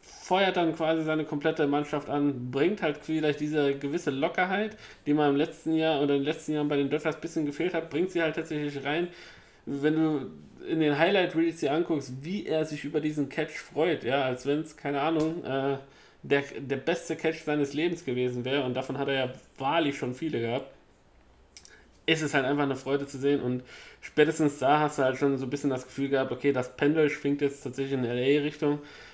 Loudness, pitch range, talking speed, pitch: -28 LUFS, 135-160 Hz, 210 wpm, 145 Hz